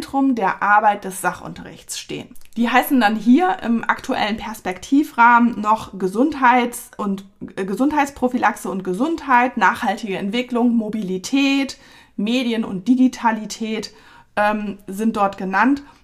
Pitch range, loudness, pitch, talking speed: 200-255 Hz, -19 LUFS, 230 Hz, 110 wpm